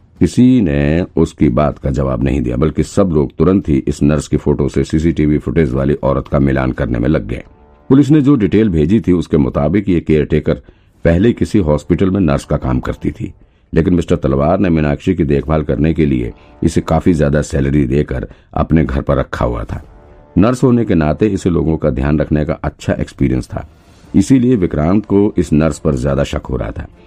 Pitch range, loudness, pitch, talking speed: 70-90 Hz, -14 LUFS, 75 Hz, 200 wpm